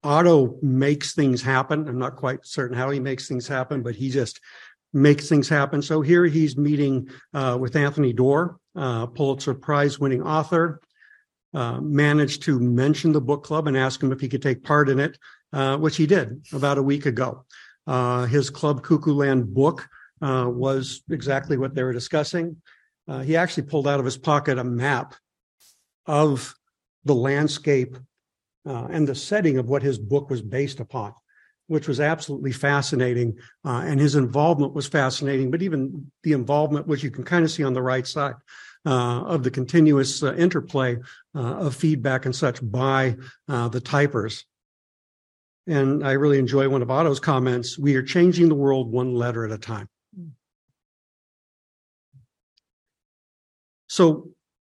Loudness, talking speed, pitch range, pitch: -22 LUFS, 165 wpm, 130-150 Hz, 140 Hz